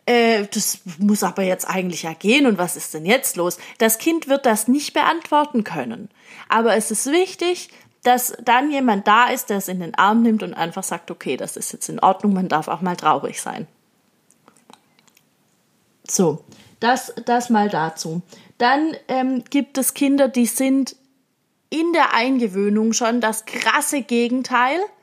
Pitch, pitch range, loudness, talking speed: 230 Hz, 200-260 Hz, -19 LUFS, 165 wpm